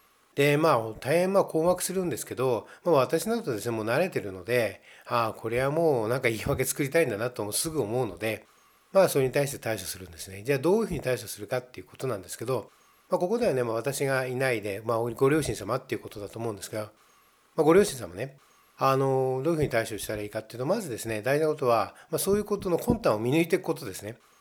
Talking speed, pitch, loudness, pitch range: 485 characters per minute, 130 Hz, -27 LUFS, 110-160 Hz